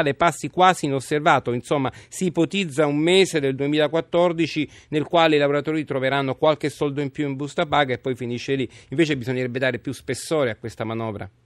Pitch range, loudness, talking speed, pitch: 130-155 Hz, -22 LUFS, 180 wpm, 145 Hz